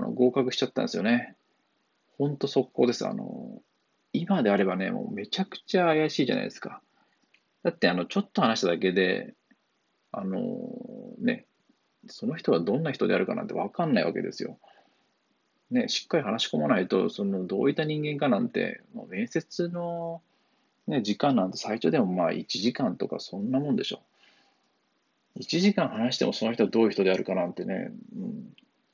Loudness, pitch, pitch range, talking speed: -28 LUFS, 195 Hz, 145-235 Hz, 345 characters per minute